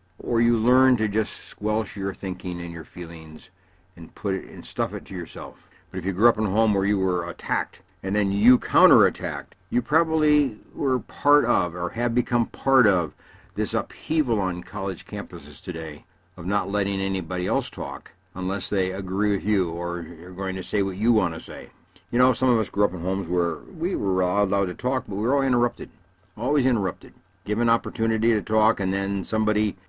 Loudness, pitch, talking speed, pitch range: -24 LUFS, 100 Hz, 205 wpm, 95-115 Hz